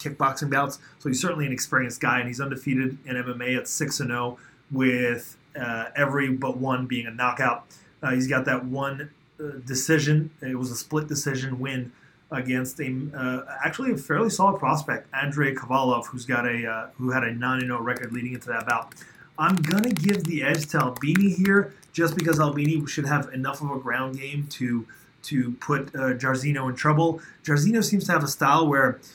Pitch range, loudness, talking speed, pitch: 125-150 Hz, -25 LUFS, 190 wpm, 135 Hz